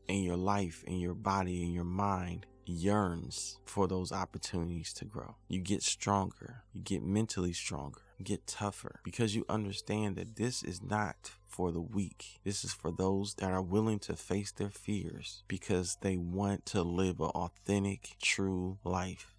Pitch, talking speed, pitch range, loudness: 95 Hz, 170 wpm, 90-100 Hz, -36 LUFS